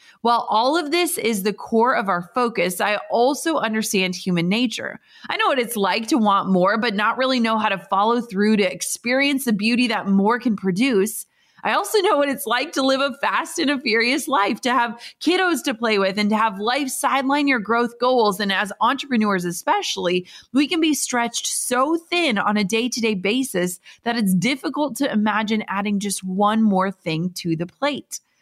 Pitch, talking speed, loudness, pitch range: 225 Hz, 205 wpm, -20 LUFS, 200-260 Hz